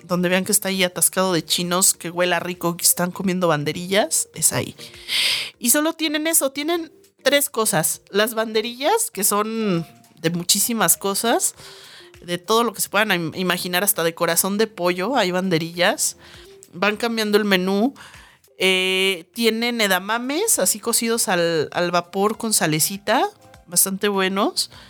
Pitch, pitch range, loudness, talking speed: 195 Hz, 175-225 Hz, -19 LUFS, 150 wpm